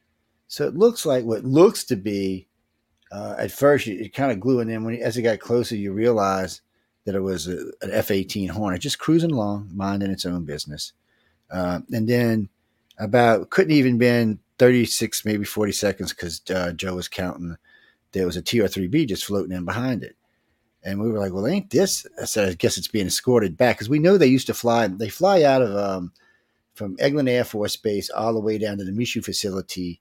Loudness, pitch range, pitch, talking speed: -22 LUFS, 95-120 Hz, 105 Hz, 205 wpm